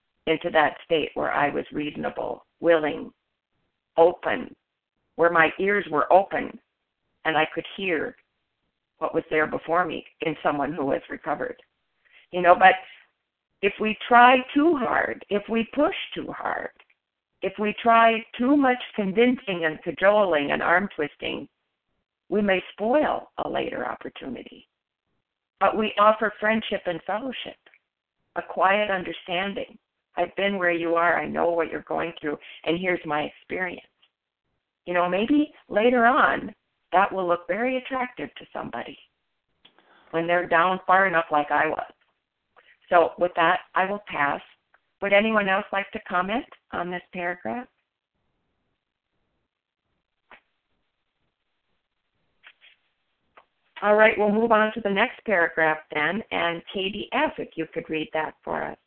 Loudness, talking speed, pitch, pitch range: -23 LUFS, 140 wpm, 190 Hz, 165-220 Hz